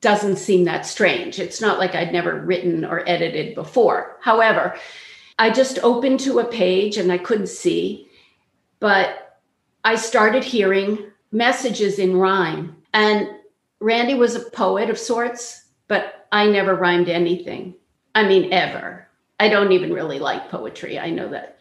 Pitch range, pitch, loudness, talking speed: 185-235 Hz, 205 Hz, -19 LUFS, 155 wpm